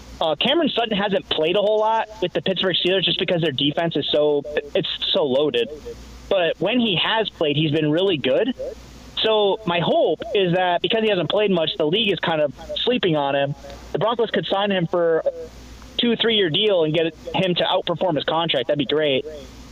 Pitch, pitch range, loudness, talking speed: 185 Hz, 160-215 Hz, -20 LUFS, 205 wpm